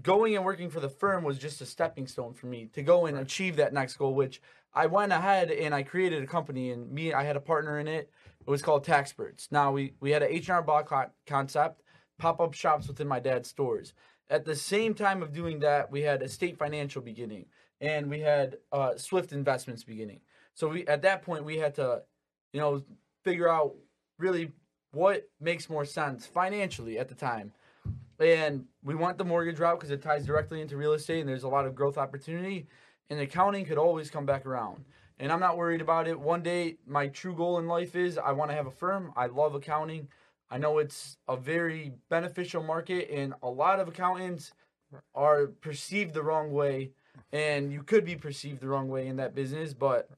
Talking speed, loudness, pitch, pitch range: 215 wpm, -30 LUFS, 150 Hz, 140-170 Hz